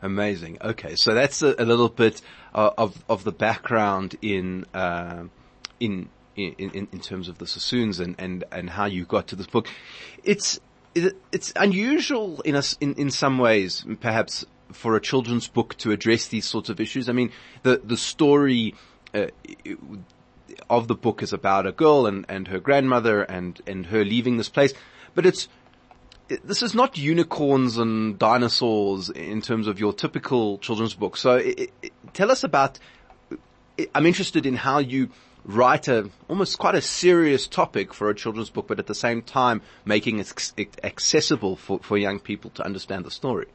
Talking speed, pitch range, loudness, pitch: 180 wpm, 100-140 Hz, -23 LUFS, 115 Hz